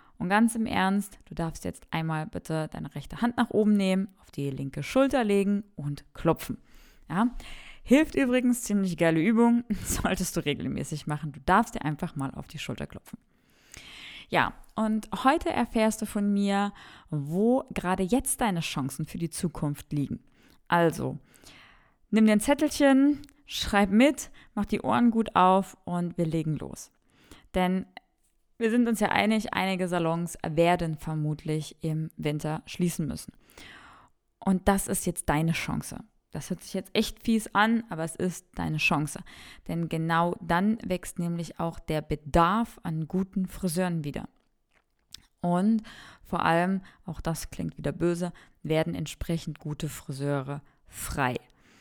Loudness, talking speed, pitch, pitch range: -28 LUFS, 150 wpm, 180 Hz, 160-215 Hz